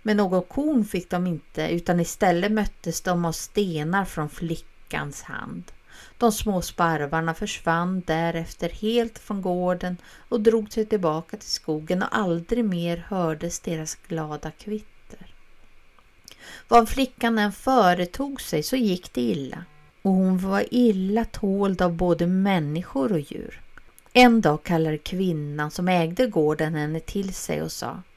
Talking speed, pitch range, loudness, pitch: 145 wpm, 165-210 Hz, -24 LUFS, 180 Hz